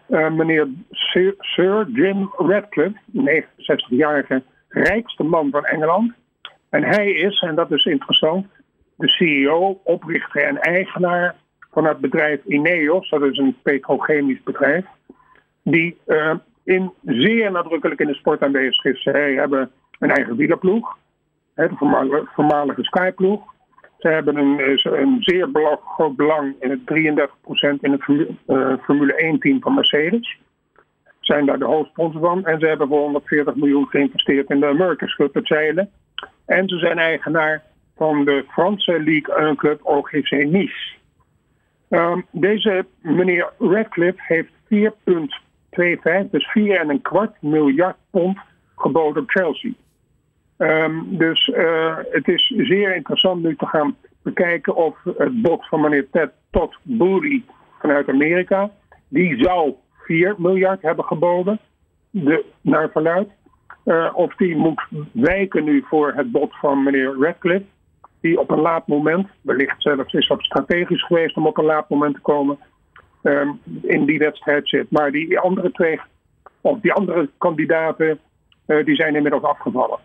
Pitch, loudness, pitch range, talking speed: 165 Hz, -18 LUFS, 150-190 Hz, 140 wpm